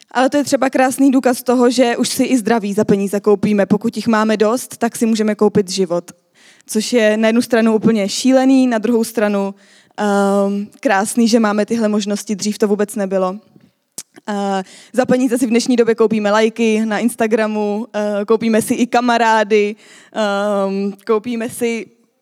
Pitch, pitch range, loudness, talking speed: 220 Hz, 205-235 Hz, -16 LUFS, 170 wpm